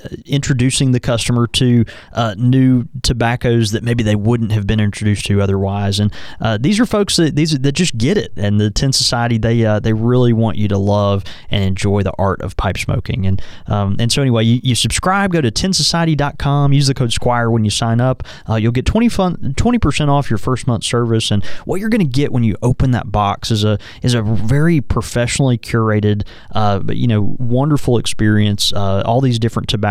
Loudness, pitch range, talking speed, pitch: -15 LUFS, 105-130 Hz, 210 wpm, 115 Hz